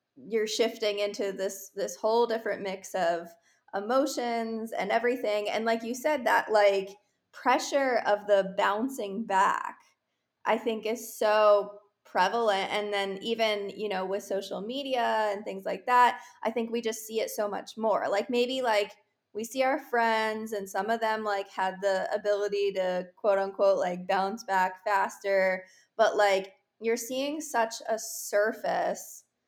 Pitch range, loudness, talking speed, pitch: 200-230 Hz, -28 LUFS, 160 wpm, 215 Hz